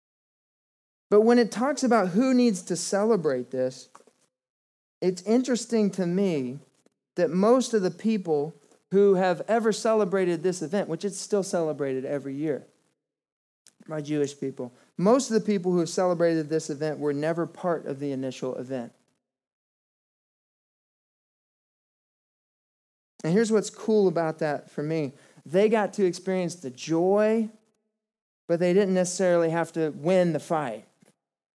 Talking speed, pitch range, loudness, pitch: 140 wpm, 155-210 Hz, -25 LUFS, 180 Hz